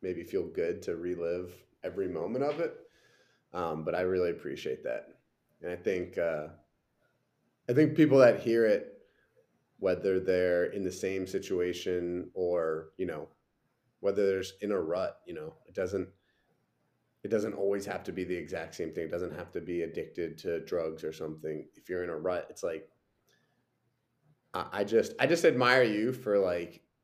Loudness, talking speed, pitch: -31 LUFS, 175 wpm, 95 Hz